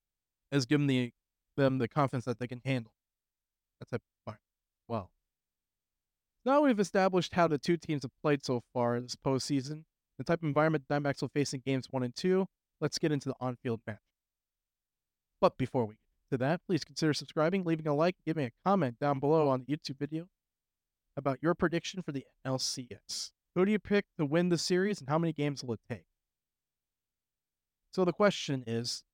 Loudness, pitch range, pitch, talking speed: -32 LUFS, 125-165 Hz, 145 Hz, 200 wpm